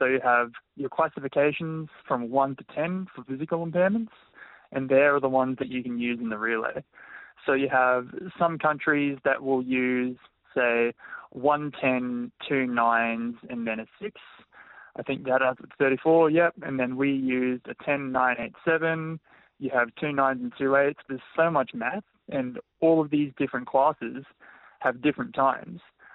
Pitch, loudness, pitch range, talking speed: 135 Hz, -26 LUFS, 125-160 Hz, 175 wpm